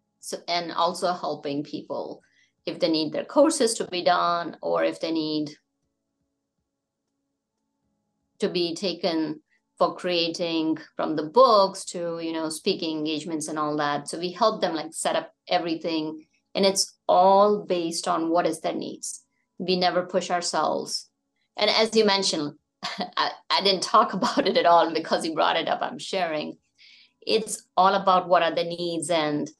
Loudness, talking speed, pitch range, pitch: -24 LUFS, 165 wpm, 160-190 Hz, 175 Hz